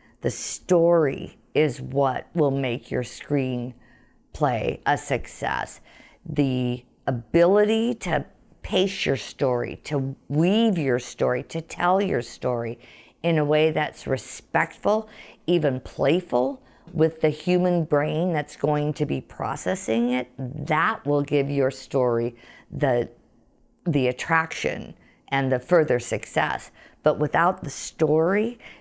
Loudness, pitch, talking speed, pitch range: -24 LUFS, 145 Hz, 120 wpm, 125-165 Hz